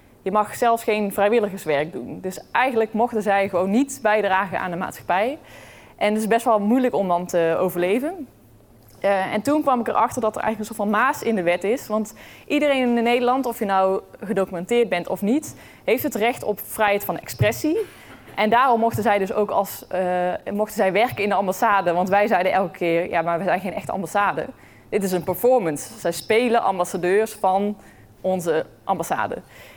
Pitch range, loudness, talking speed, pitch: 185-230 Hz, -21 LUFS, 195 wpm, 205 Hz